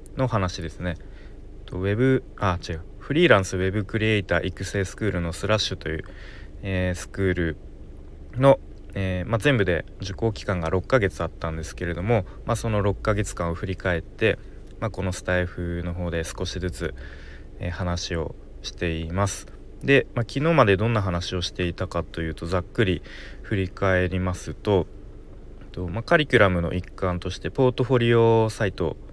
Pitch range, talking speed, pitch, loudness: 85-105 Hz, 335 characters per minute, 95 Hz, -24 LUFS